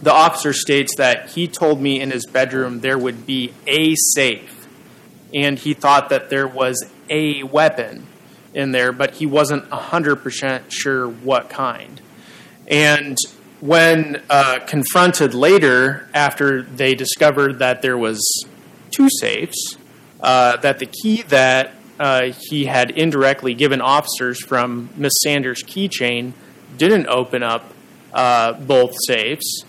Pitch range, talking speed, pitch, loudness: 125-150 Hz, 135 wpm, 135 Hz, -16 LUFS